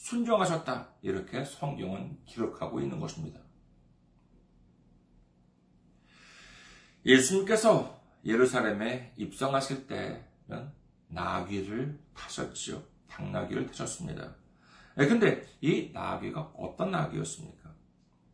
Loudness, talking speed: -31 LUFS, 215 characters per minute